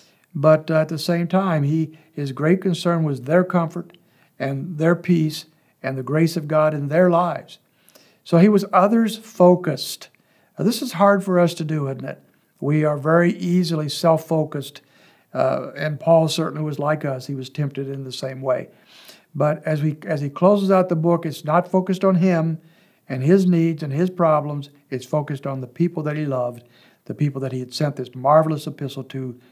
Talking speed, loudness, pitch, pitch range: 195 wpm, -20 LUFS, 155 Hz, 145-175 Hz